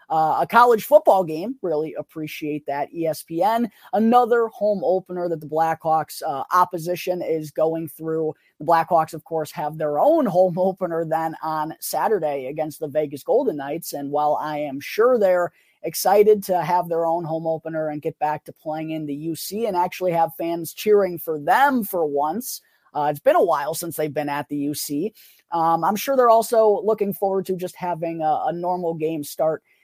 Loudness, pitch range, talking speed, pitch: -22 LUFS, 155-185 Hz, 185 wpm, 165 Hz